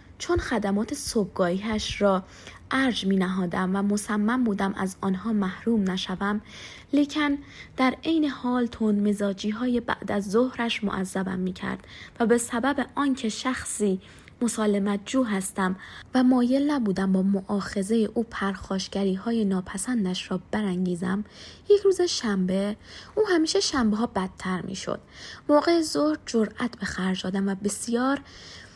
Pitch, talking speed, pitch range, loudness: 210 Hz, 135 wpm, 195-250 Hz, -26 LUFS